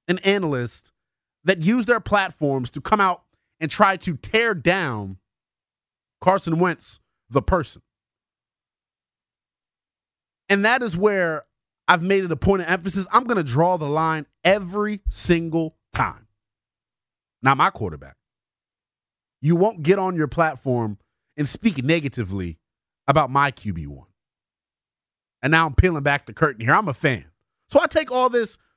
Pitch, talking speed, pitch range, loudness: 160 Hz, 140 wpm, 130-195 Hz, -21 LUFS